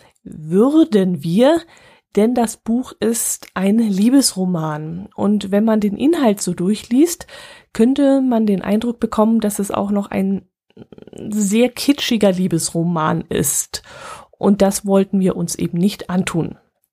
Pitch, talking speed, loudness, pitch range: 205 Hz, 130 wpm, -17 LUFS, 185-235 Hz